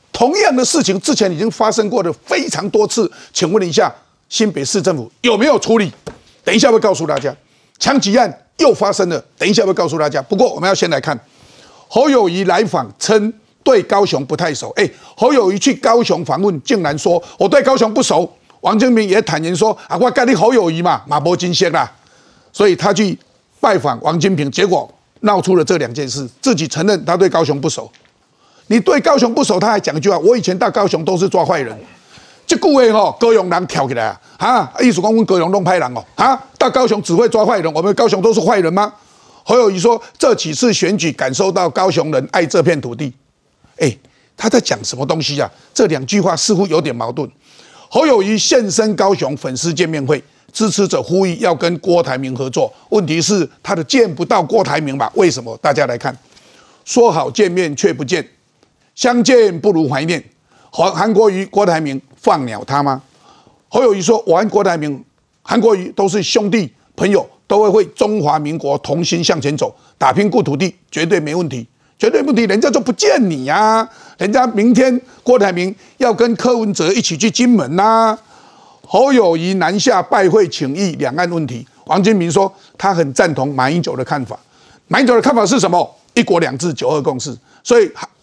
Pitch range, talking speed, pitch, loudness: 165-225 Hz, 290 characters per minute, 195 Hz, -14 LUFS